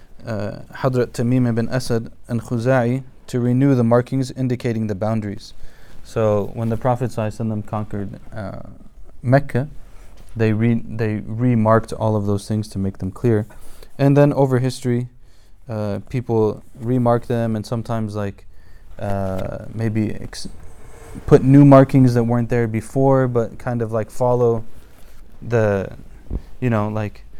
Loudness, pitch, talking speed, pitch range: -19 LUFS, 115 Hz, 145 wpm, 105-125 Hz